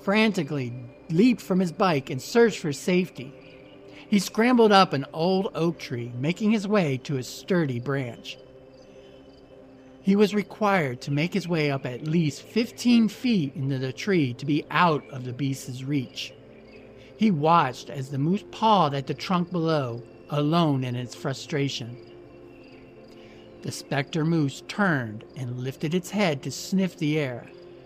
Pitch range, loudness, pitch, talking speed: 130-185 Hz, -25 LUFS, 145 Hz, 155 wpm